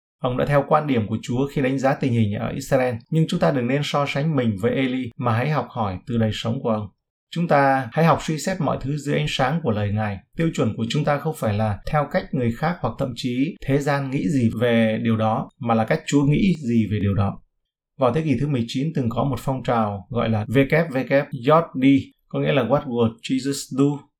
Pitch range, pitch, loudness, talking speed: 115-145 Hz, 130 Hz, -22 LUFS, 245 wpm